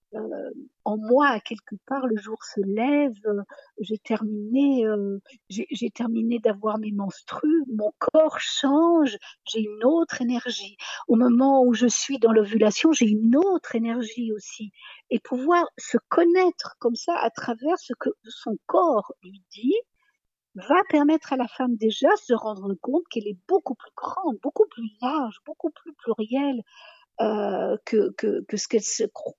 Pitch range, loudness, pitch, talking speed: 215-290 Hz, -24 LUFS, 240 Hz, 165 wpm